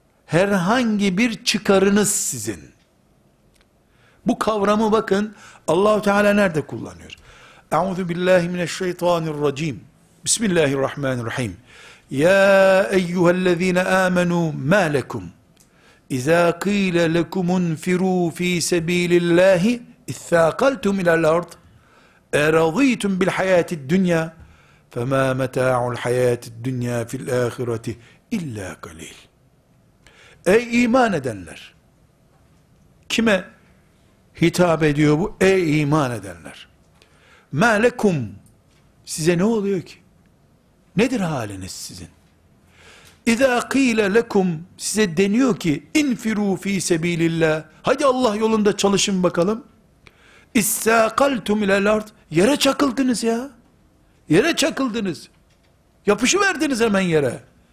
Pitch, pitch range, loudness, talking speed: 180 Hz, 155-210 Hz, -19 LUFS, 95 wpm